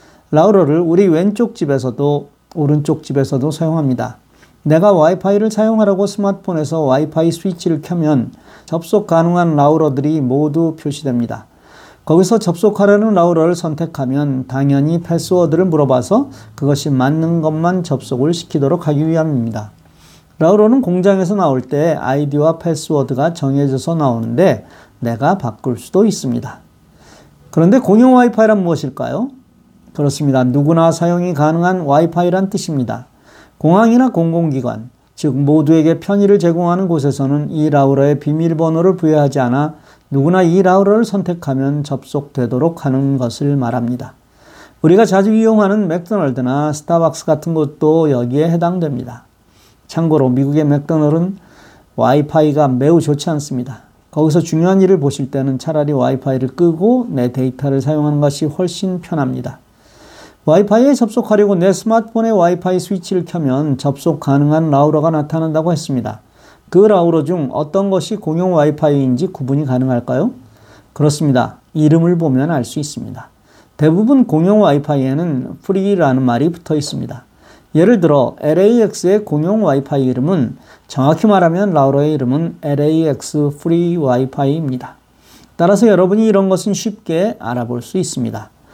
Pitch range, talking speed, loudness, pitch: 135-180 Hz, 355 characters per minute, -14 LUFS, 155 Hz